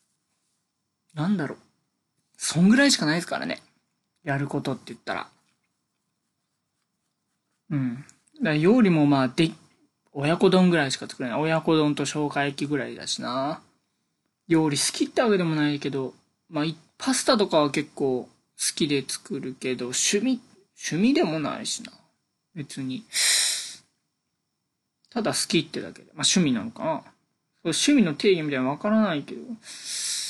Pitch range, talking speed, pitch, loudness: 140-210 Hz, 280 characters per minute, 155 Hz, -24 LUFS